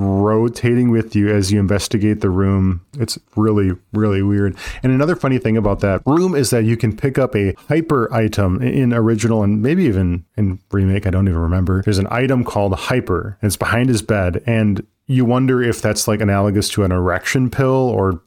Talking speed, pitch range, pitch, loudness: 200 wpm, 95-120 Hz, 105 Hz, -17 LUFS